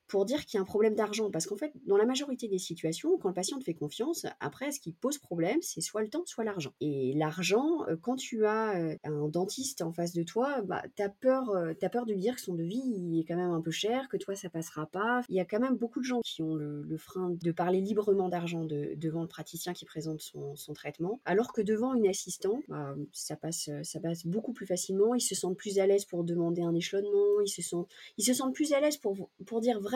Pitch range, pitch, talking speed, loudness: 170-230 Hz, 195 Hz, 260 wpm, -32 LUFS